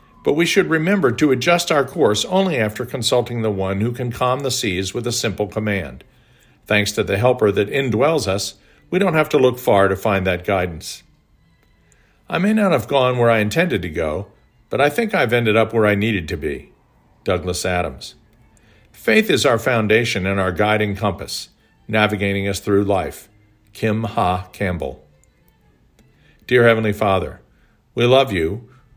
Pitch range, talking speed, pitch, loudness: 100-125 Hz, 170 wpm, 110 Hz, -18 LUFS